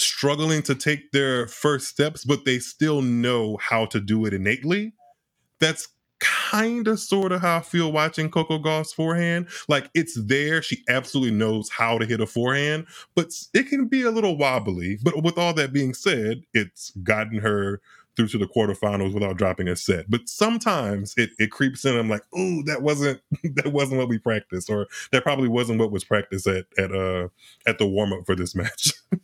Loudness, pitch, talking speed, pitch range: -23 LUFS, 130 Hz, 195 wpm, 110-160 Hz